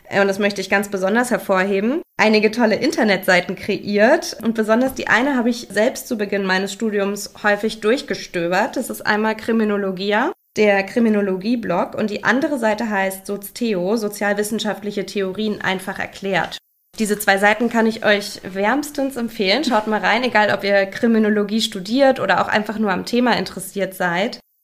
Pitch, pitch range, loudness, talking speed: 210 Hz, 195-225 Hz, -19 LUFS, 155 wpm